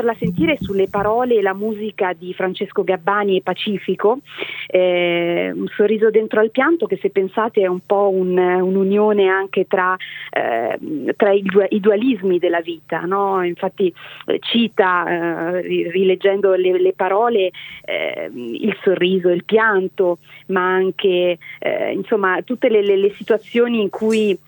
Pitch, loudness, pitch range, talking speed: 195 Hz, -18 LUFS, 185-215 Hz, 150 wpm